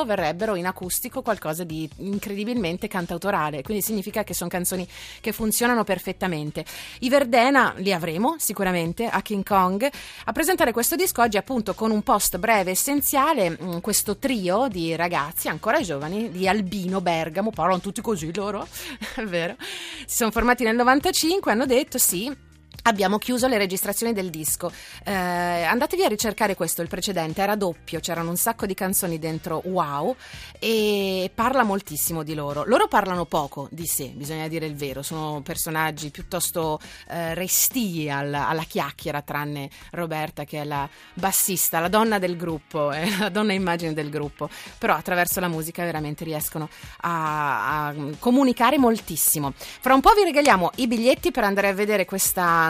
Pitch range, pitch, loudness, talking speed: 165-220 Hz, 185 Hz, -23 LUFS, 160 wpm